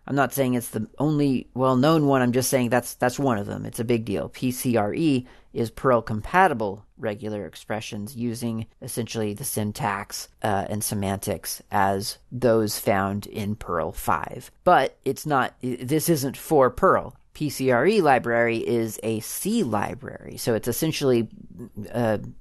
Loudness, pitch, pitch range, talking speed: -24 LUFS, 115 Hz, 105-130 Hz, 145 wpm